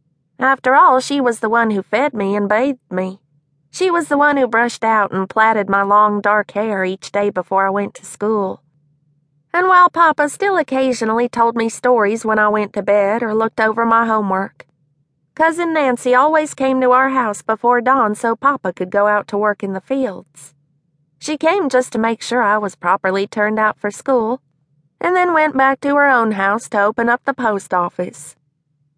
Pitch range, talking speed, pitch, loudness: 190-255 Hz, 200 wpm, 215 Hz, -16 LUFS